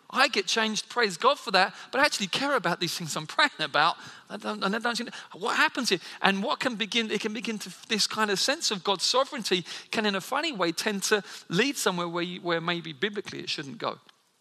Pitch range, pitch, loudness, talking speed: 185-240 Hz, 210 Hz, -27 LUFS, 235 wpm